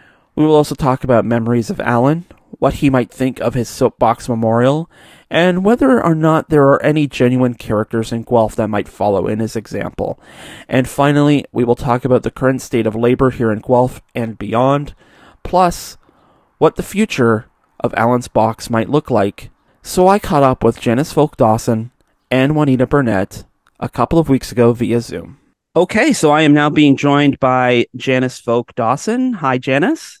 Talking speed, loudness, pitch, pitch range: 180 wpm, -15 LUFS, 130 Hz, 115-145 Hz